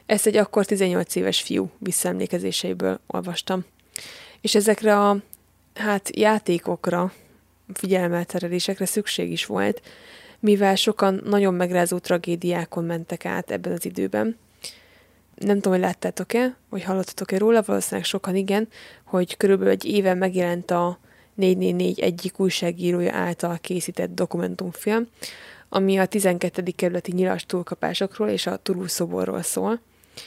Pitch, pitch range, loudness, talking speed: 185 Hz, 175-205 Hz, -23 LUFS, 115 wpm